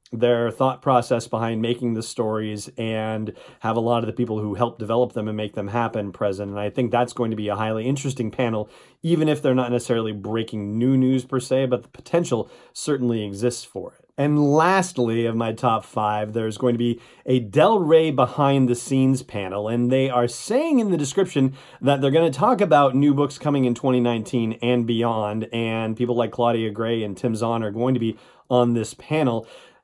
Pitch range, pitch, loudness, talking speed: 110-130 Hz, 120 Hz, -22 LUFS, 205 wpm